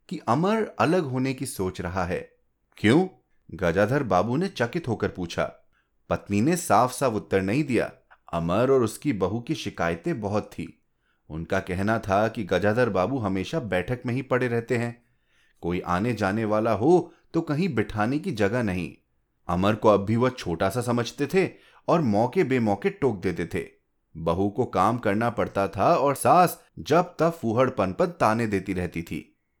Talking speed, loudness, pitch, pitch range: 170 wpm, -25 LUFS, 110 Hz, 95-135 Hz